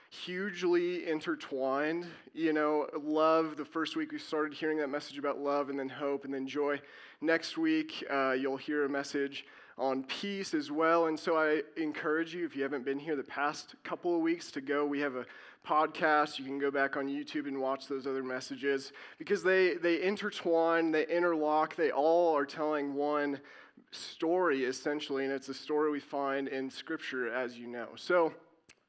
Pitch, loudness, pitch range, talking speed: 150 Hz, -33 LUFS, 140-165 Hz, 185 wpm